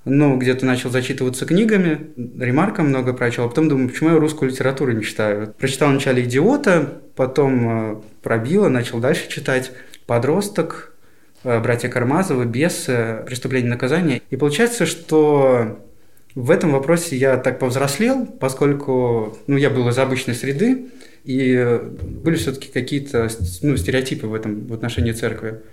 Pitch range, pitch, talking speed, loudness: 120-150 Hz, 130 Hz, 135 wpm, -19 LUFS